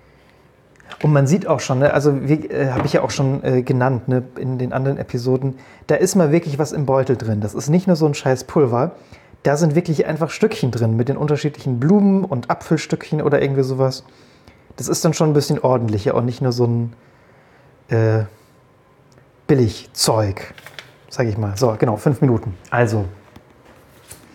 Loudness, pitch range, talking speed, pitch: -18 LUFS, 125-150 Hz, 175 wpm, 135 Hz